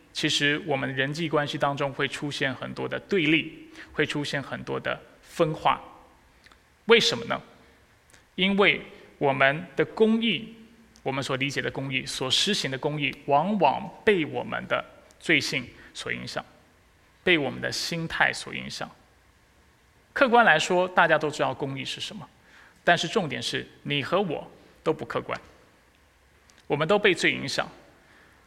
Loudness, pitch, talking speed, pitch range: -25 LUFS, 150 Hz, 220 characters per minute, 135-185 Hz